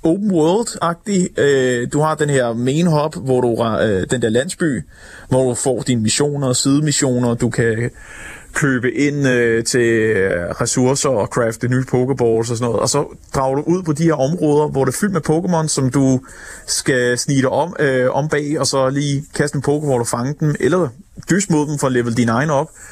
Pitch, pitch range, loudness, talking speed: 135 Hz, 125-150 Hz, -17 LUFS, 195 wpm